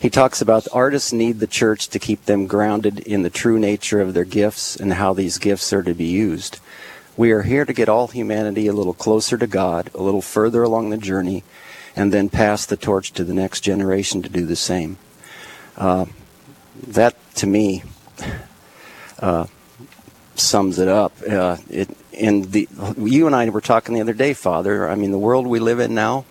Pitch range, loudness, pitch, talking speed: 95-115 Hz, -19 LUFS, 105 Hz, 190 wpm